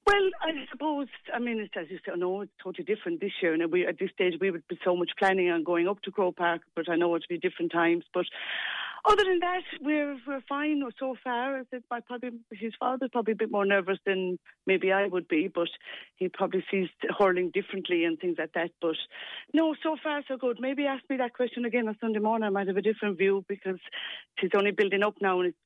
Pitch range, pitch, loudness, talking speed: 180-250 Hz, 200 Hz, -29 LUFS, 235 wpm